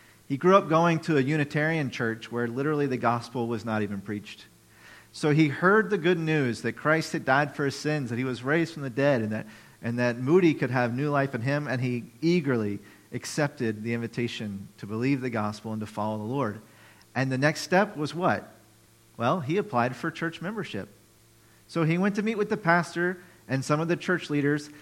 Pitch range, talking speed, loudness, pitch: 115-160 Hz, 215 wpm, -27 LUFS, 135 Hz